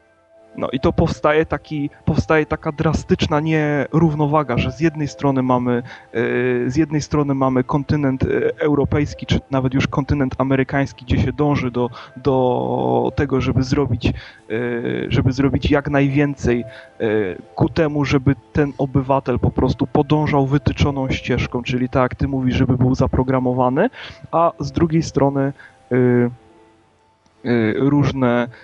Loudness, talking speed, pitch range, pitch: -19 LUFS, 125 wpm, 125-145 Hz, 135 Hz